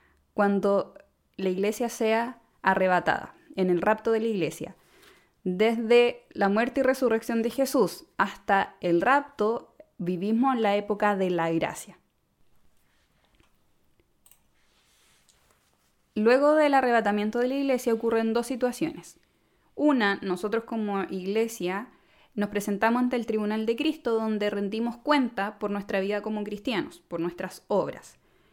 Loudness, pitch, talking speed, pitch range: -26 LUFS, 215 Hz, 125 wpm, 195-240 Hz